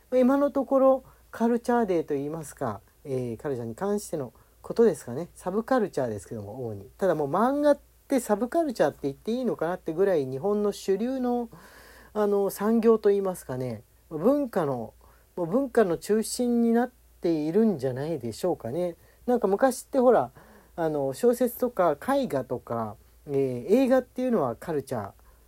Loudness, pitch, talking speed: -27 LUFS, 190 Hz, 365 characters per minute